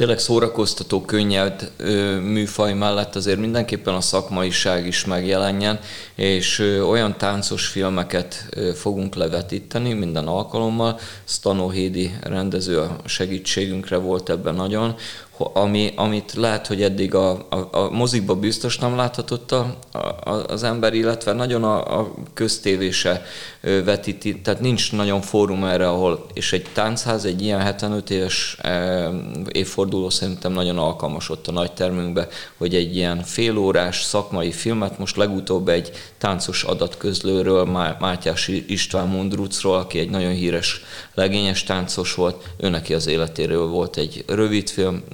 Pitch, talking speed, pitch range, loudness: 95 Hz, 130 wpm, 90-105 Hz, -21 LUFS